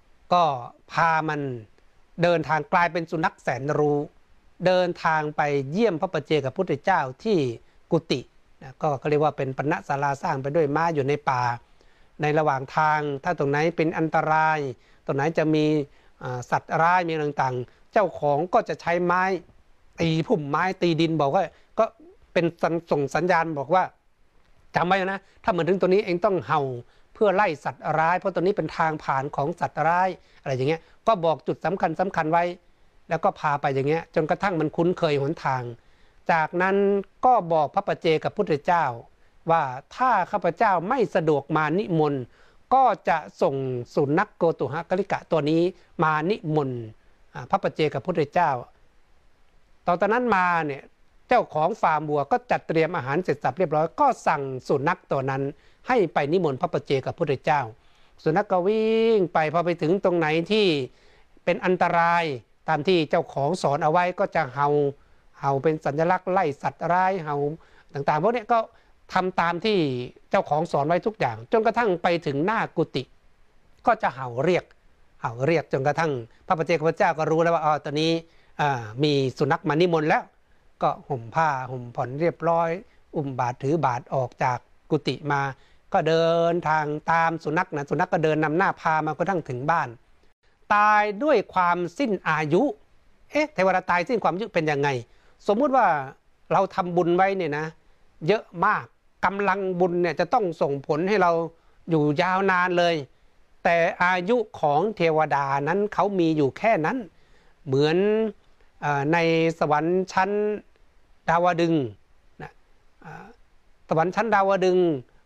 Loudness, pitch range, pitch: -24 LUFS, 145-180 Hz, 165 Hz